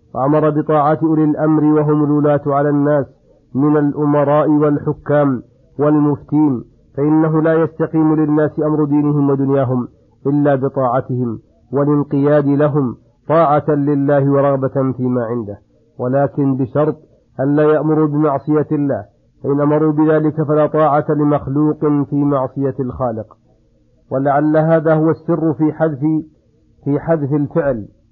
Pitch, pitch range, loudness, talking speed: 145 Hz, 135-155 Hz, -15 LUFS, 115 wpm